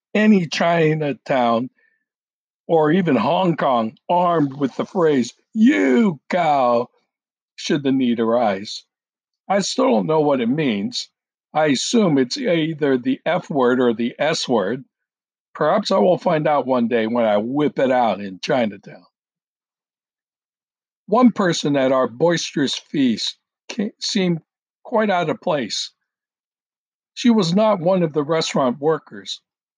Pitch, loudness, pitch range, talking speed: 170 Hz, -19 LUFS, 135-215 Hz, 135 wpm